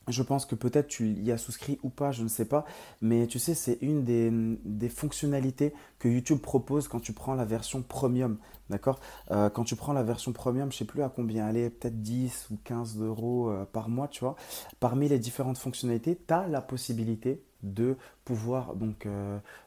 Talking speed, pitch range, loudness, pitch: 205 wpm, 115-135 Hz, -31 LUFS, 125 Hz